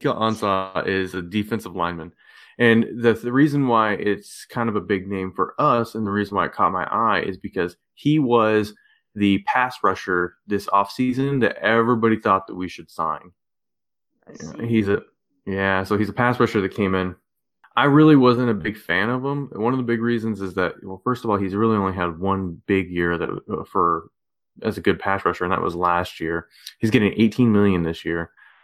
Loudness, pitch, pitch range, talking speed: -21 LUFS, 105 Hz, 95-115 Hz, 205 wpm